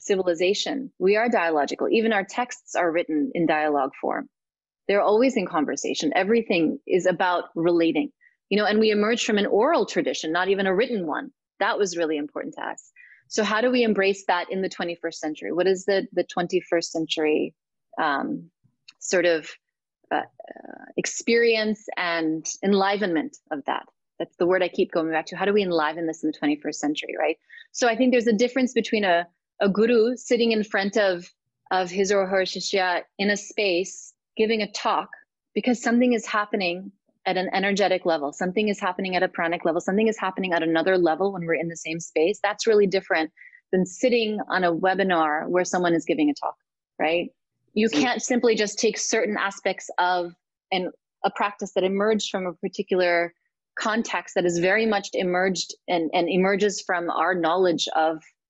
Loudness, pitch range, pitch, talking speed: -24 LUFS, 175-215 Hz, 190 Hz, 185 wpm